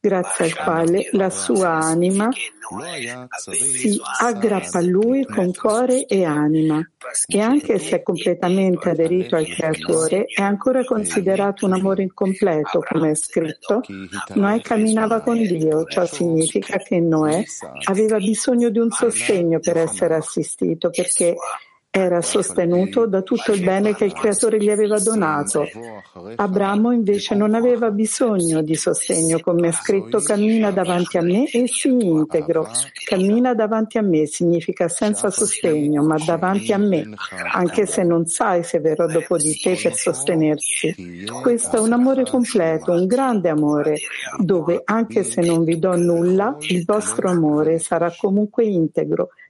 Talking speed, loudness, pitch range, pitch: 145 wpm, -19 LUFS, 165-215 Hz, 185 Hz